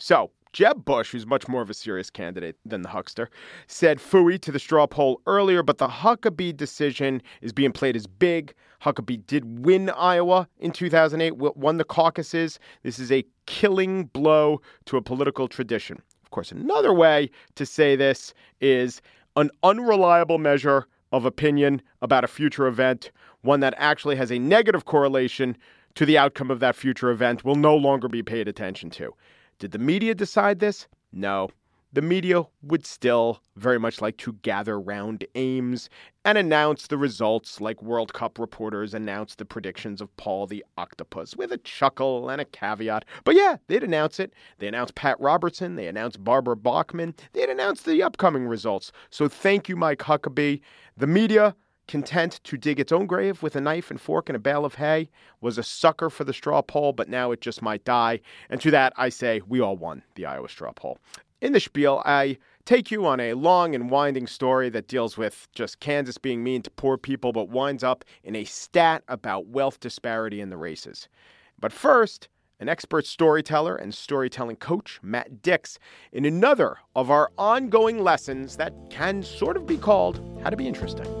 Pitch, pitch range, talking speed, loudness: 140 Hz, 120-165 Hz, 185 wpm, -23 LUFS